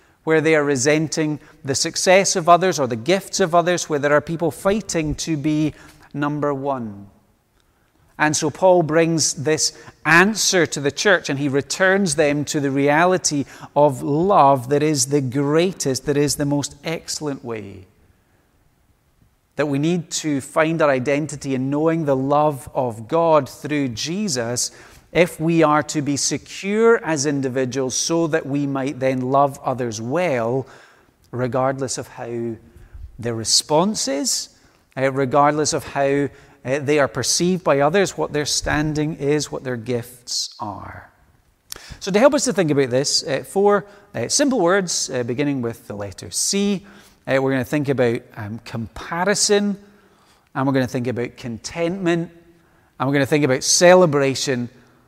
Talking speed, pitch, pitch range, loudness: 150 wpm, 145 Hz, 130-165 Hz, -19 LUFS